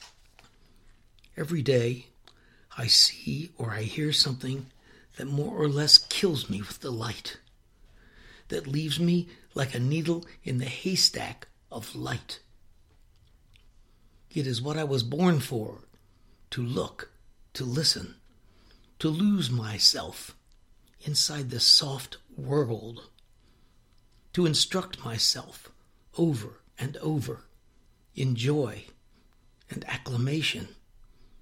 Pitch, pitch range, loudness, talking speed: 130 Hz, 115-150 Hz, -26 LUFS, 105 wpm